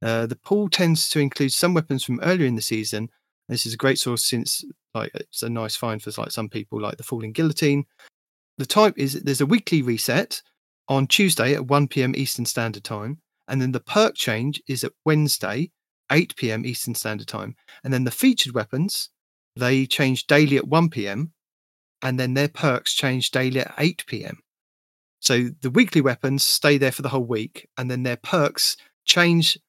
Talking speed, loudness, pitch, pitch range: 185 wpm, -22 LUFS, 135 Hz, 120-150 Hz